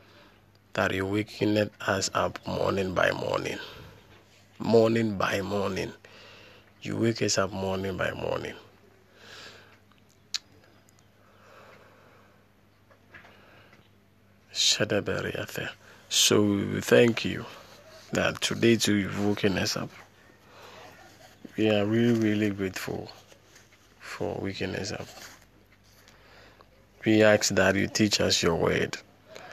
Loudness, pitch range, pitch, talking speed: -26 LUFS, 100-110 Hz, 105 Hz, 90 wpm